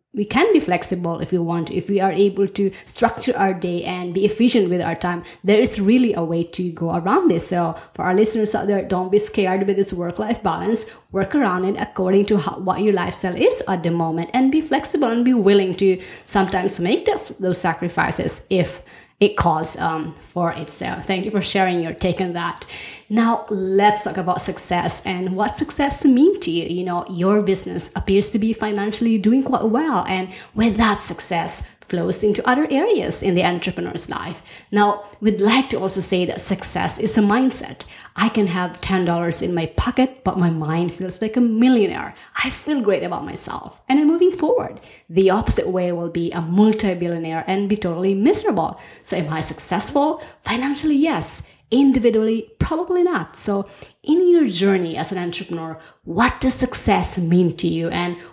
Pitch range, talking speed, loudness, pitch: 180-230 Hz, 190 wpm, -20 LUFS, 195 Hz